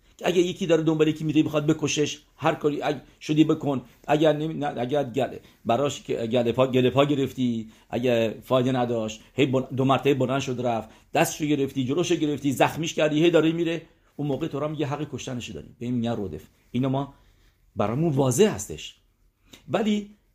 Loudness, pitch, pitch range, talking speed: -25 LUFS, 140 Hz, 120-155 Hz, 165 wpm